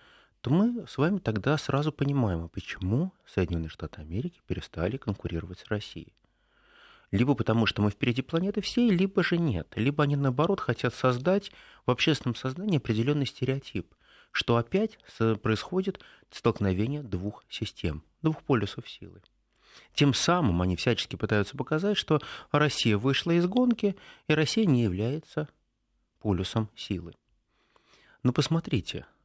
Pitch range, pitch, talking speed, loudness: 105-155 Hz, 130 Hz, 130 wpm, -28 LUFS